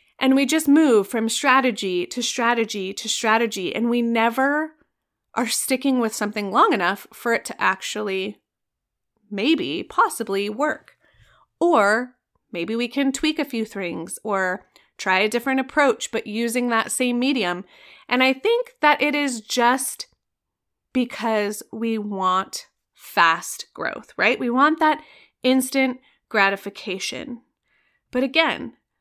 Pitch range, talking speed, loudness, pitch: 210-275 Hz, 130 wpm, -21 LUFS, 240 Hz